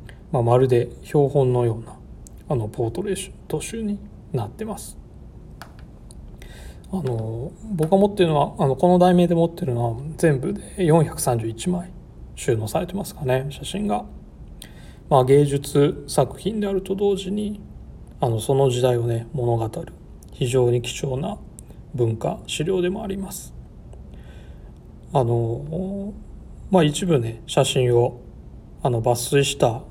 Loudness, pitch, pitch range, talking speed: -22 LUFS, 140 Hz, 120-180 Hz, 255 characters per minute